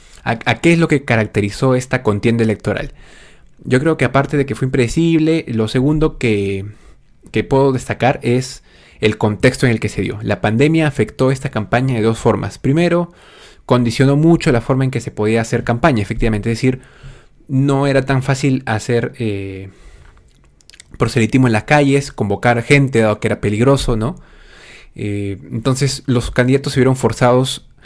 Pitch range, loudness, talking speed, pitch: 110-135 Hz, -16 LUFS, 165 wpm, 125 Hz